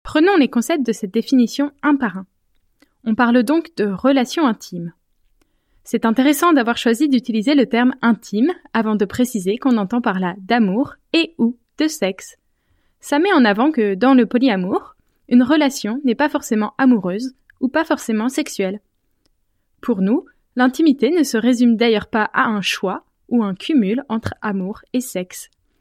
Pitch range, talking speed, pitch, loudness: 220-285 Hz, 165 wpm, 245 Hz, -18 LUFS